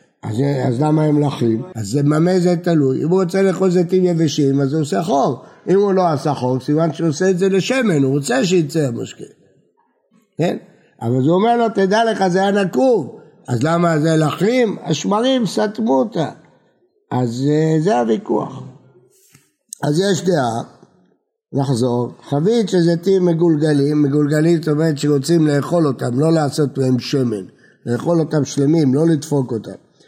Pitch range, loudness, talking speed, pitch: 140-185 Hz, -17 LUFS, 160 wpm, 155 Hz